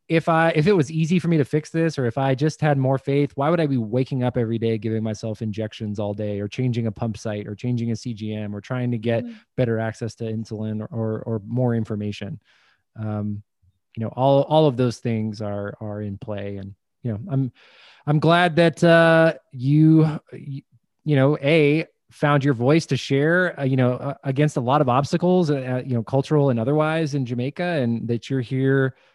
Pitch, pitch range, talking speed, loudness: 125 Hz, 110-150 Hz, 210 wpm, -22 LUFS